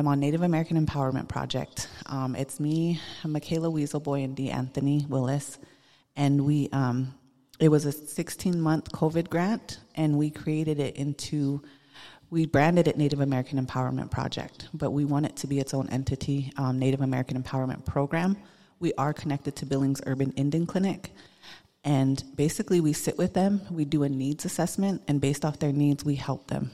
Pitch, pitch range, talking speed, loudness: 145 Hz, 135-155 Hz, 175 wpm, -28 LUFS